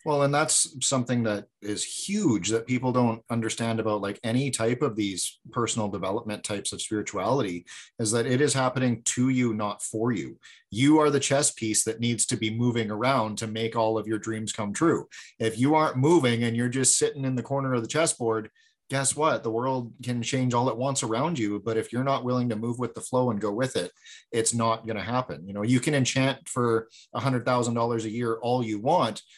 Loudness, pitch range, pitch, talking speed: -26 LUFS, 110-130 Hz, 120 Hz, 225 wpm